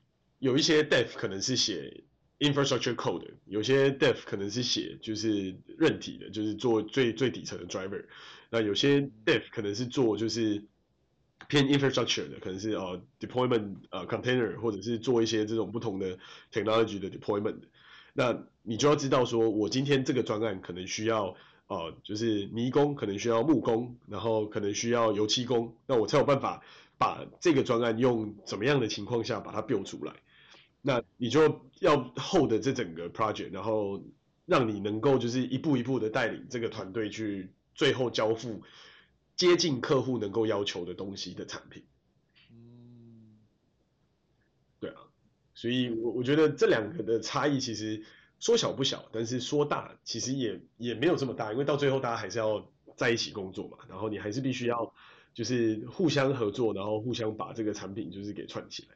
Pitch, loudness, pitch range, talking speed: 115 Hz, -30 LUFS, 105-130 Hz, 355 characters per minute